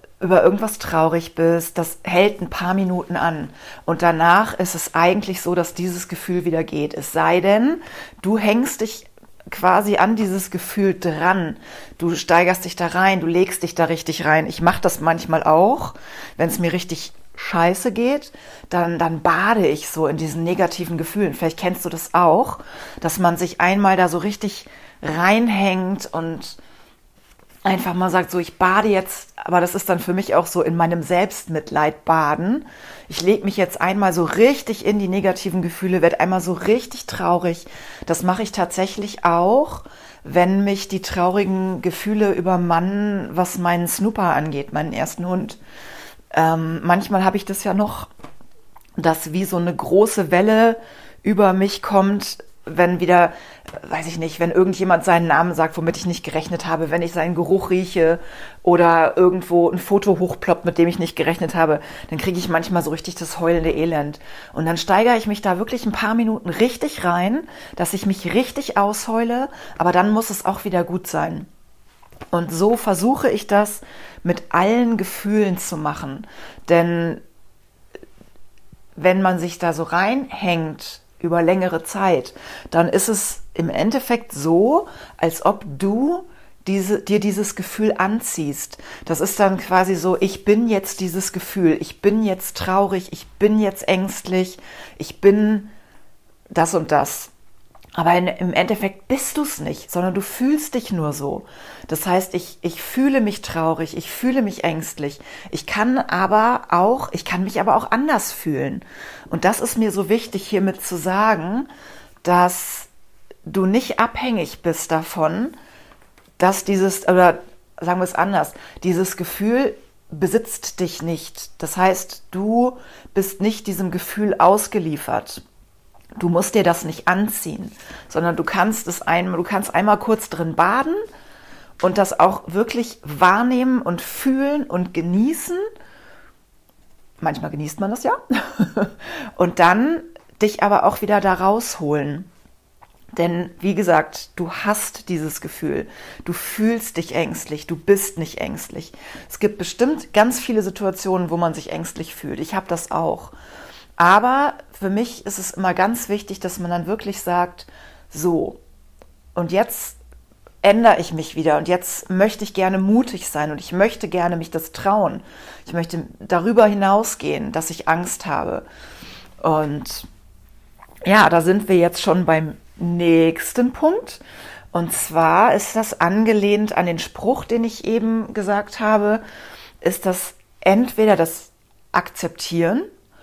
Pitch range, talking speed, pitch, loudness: 170-210 Hz, 155 wpm, 185 Hz, -19 LUFS